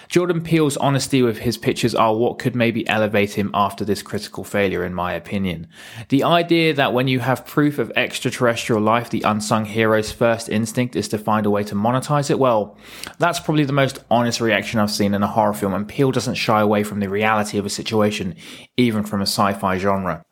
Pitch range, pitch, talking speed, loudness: 105-130 Hz, 110 Hz, 210 wpm, -19 LUFS